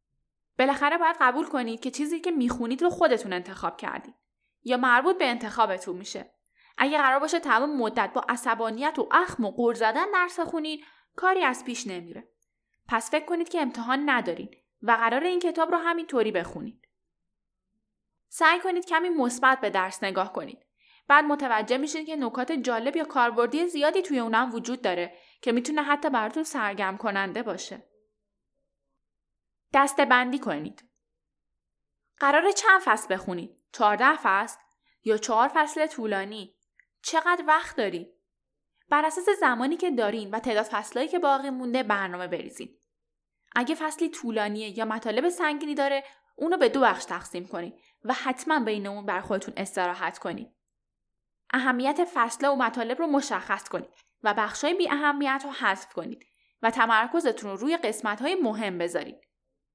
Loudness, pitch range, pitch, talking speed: -26 LUFS, 220-305 Hz, 255 Hz, 150 wpm